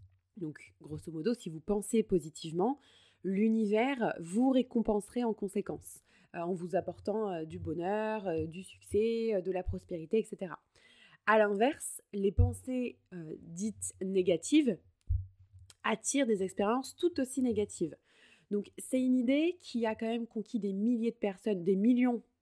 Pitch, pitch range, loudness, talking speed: 205 Hz, 175-230 Hz, -33 LUFS, 135 wpm